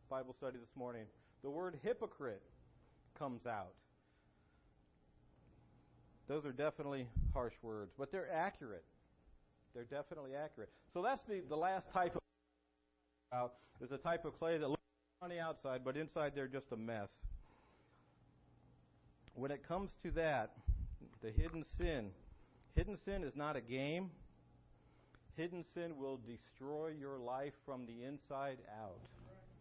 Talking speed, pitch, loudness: 135 wpm, 130 Hz, -45 LUFS